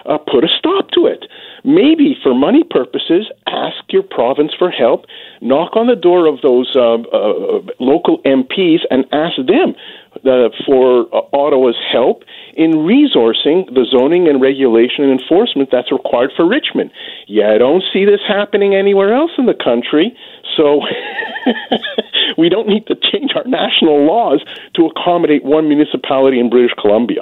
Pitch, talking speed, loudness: 175 Hz, 160 wpm, -12 LUFS